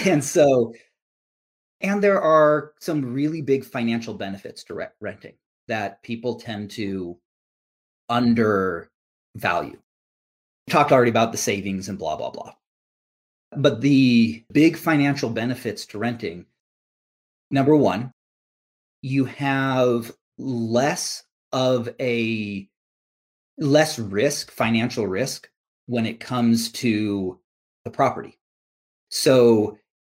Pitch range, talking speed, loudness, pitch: 105-135 Hz, 105 wpm, -22 LUFS, 120 Hz